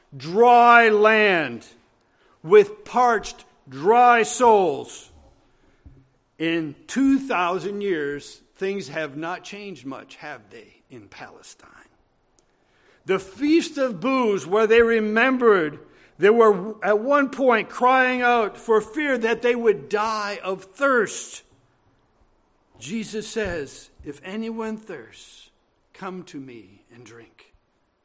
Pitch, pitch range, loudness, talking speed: 220 Hz, 190-240 Hz, -20 LUFS, 105 wpm